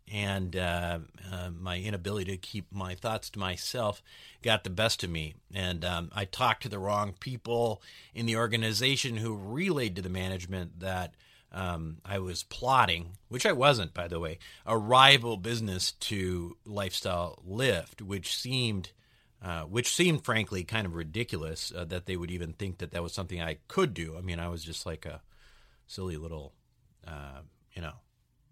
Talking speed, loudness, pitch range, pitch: 175 wpm, -31 LUFS, 85-110 Hz, 95 Hz